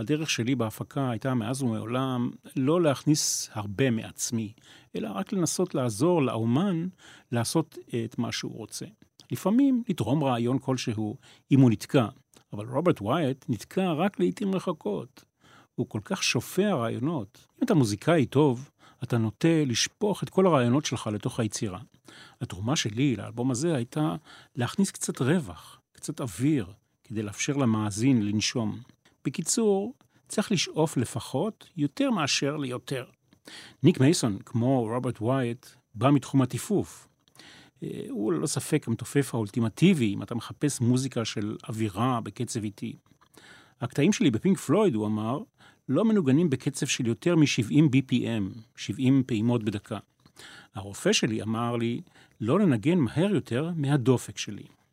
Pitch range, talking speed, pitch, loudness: 115-155 Hz, 130 wpm, 130 Hz, -27 LUFS